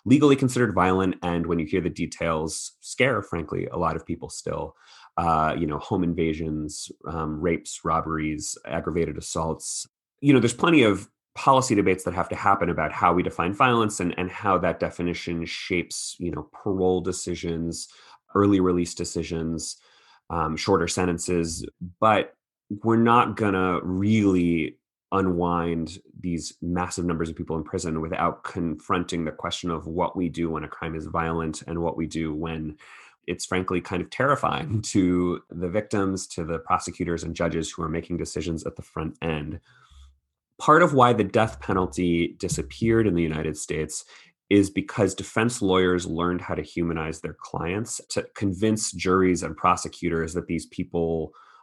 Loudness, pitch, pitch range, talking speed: -25 LUFS, 85 Hz, 80-95 Hz, 160 wpm